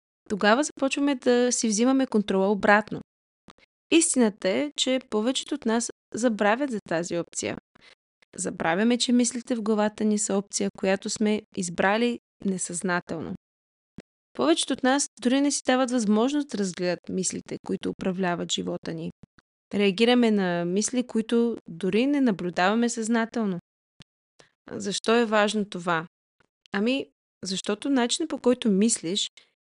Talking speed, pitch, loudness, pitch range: 125 wpm, 220 Hz, -25 LUFS, 195-245 Hz